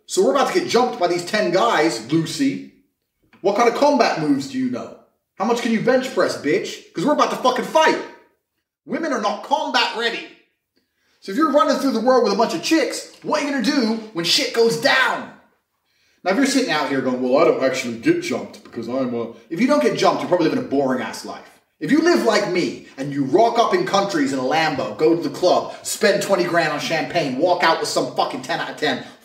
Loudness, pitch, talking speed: -19 LUFS, 230 Hz, 240 wpm